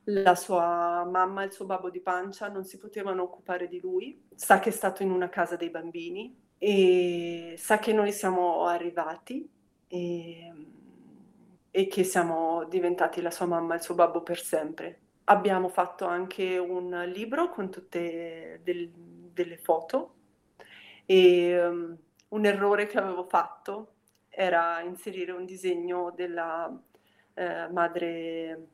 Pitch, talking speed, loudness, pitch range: 180 Hz, 140 wpm, -28 LUFS, 170-195 Hz